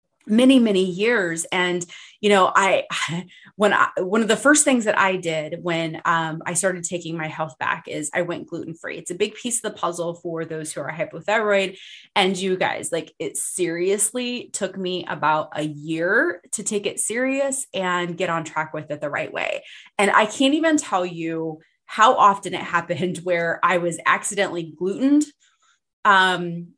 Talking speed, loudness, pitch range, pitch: 180 wpm, -21 LUFS, 170-210 Hz, 180 Hz